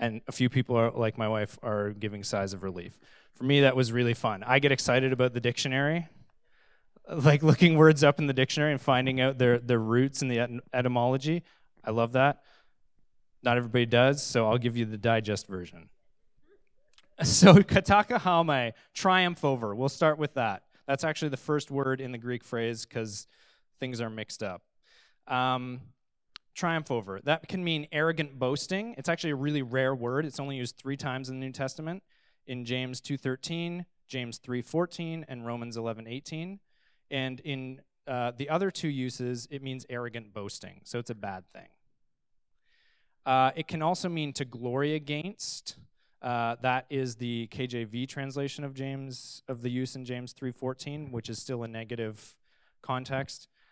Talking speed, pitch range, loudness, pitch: 170 wpm, 120-145 Hz, -28 LUFS, 130 Hz